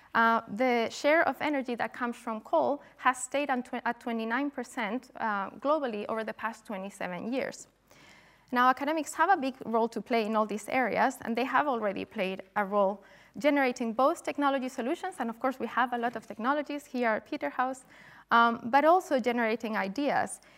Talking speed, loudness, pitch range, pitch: 180 wpm, -30 LUFS, 225-275 Hz, 245 Hz